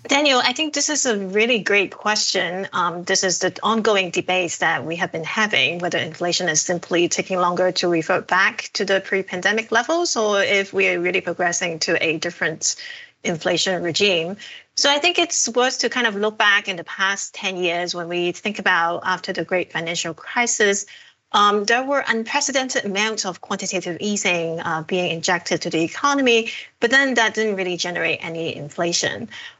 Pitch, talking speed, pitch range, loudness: 190 Hz, 185 wpm, 175-225 Hz, -20 LUFS